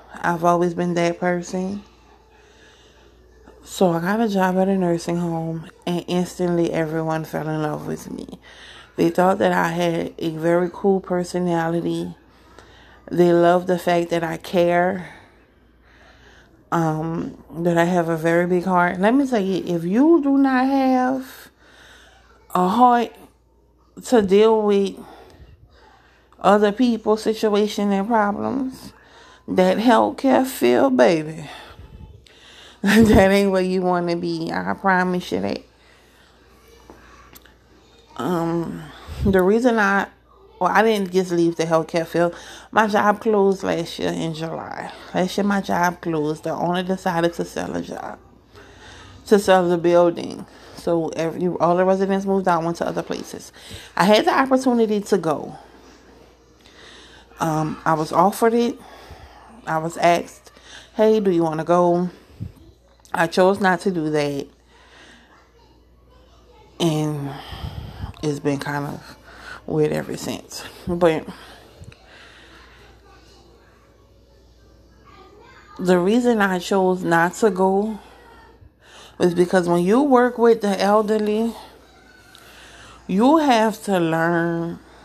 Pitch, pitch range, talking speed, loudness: 180 Hz, 165-210 Hz, 125 wpm, -20 LUFS